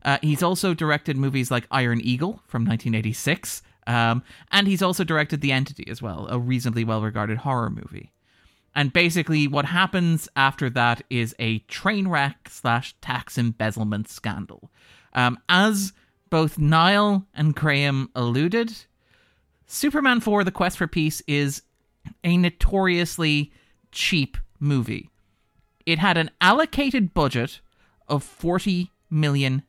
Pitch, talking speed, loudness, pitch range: 145 Hz, 130 wpm, -23 LUFS, 120-175 Hz